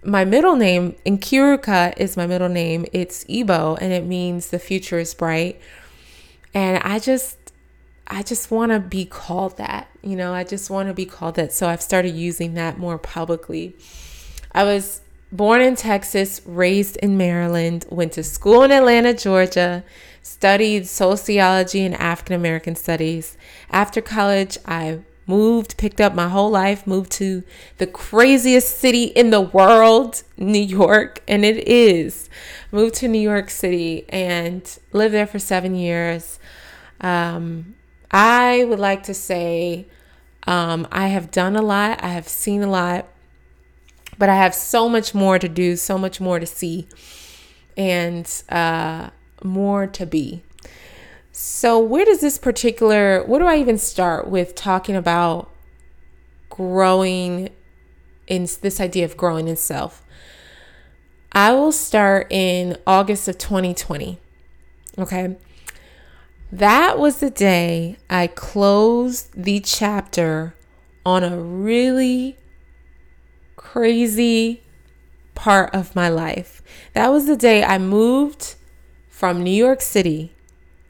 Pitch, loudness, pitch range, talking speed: 185 Hz, -18 LUFS, 170-205 Hz, 140 wpm